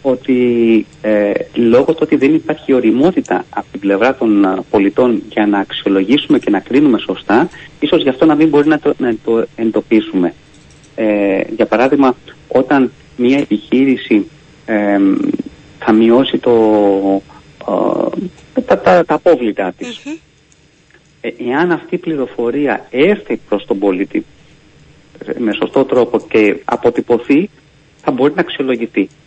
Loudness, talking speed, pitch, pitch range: -13 LUFS, 135 wpm, 130 Hz, 110-150 Hz